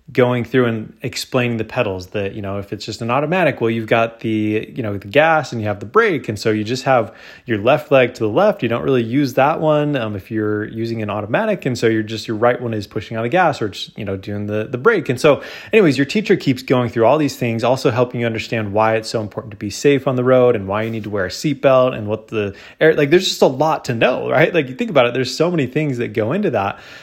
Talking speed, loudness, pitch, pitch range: 300 wpm, -17 LUFS, 115 Hz, 110-135 Hz